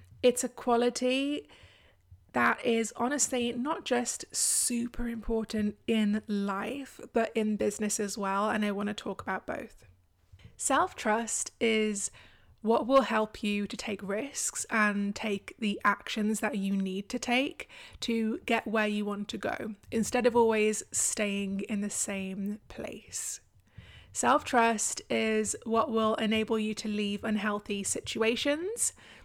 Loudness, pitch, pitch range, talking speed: -30 LUFS, 215 Hz, 205-235 Hz, 140 wpm